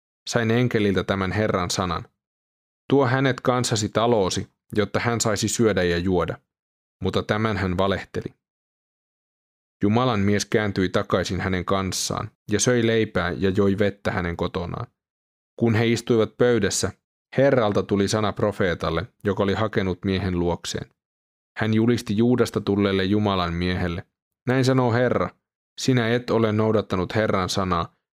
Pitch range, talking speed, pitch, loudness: 95-115 Hz, 130 wpm, 105 Hz, -23 LUFS